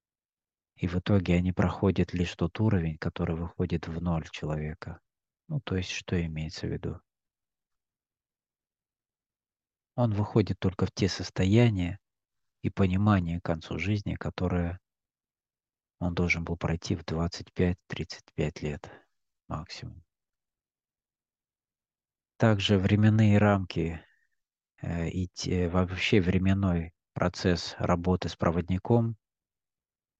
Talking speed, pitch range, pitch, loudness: 100 wpm, 85-100 Hz, 90 Hz, -29 LUFS